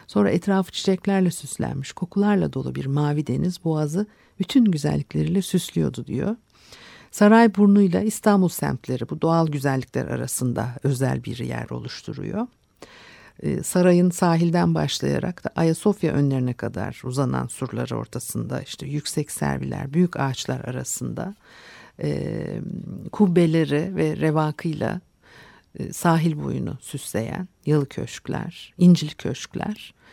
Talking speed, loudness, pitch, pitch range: 105 wpm, -23 LUFS, 160 Hz, 135-185 Hz